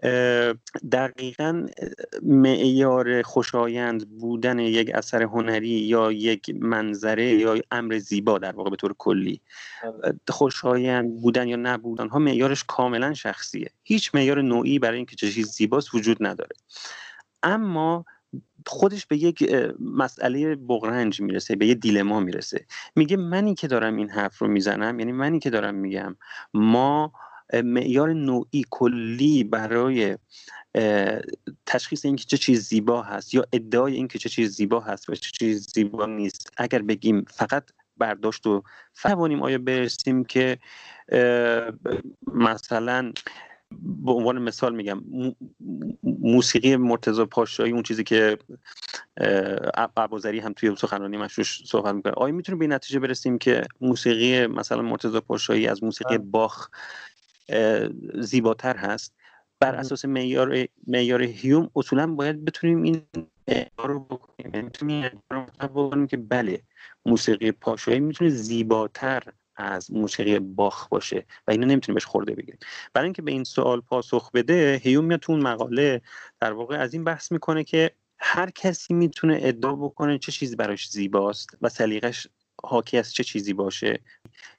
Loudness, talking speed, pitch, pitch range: -24 LUFS, 130 wpm, 125 Hz, 110-140 Hz